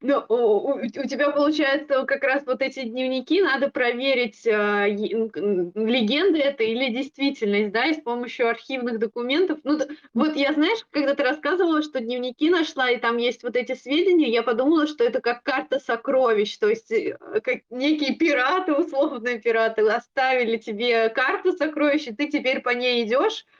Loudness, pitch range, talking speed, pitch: -22 LUFS, 240-295 Hz, 160 wpm, 265 Hz